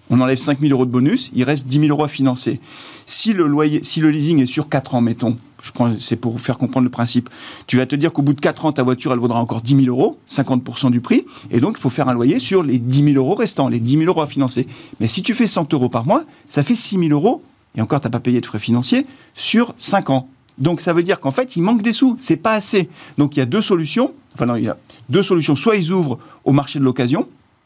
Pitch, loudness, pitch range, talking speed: 140 Hz, -17 LUFS, 125-175 Hz, 280 wpm